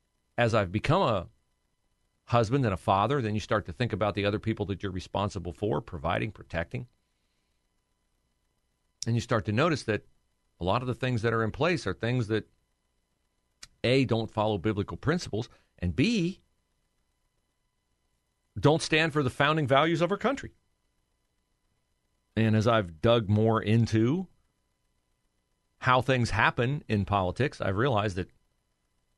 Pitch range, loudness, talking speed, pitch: 100-125 Hz, -28 LUFS, 145 wpm, 110 Hz